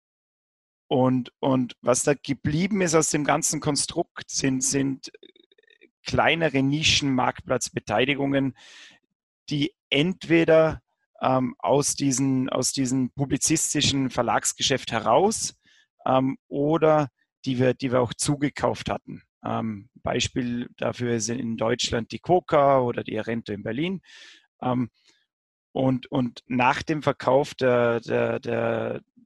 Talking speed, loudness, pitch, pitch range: 115 wpm, -24 LUFS, 135 Hz, 125-150 Hz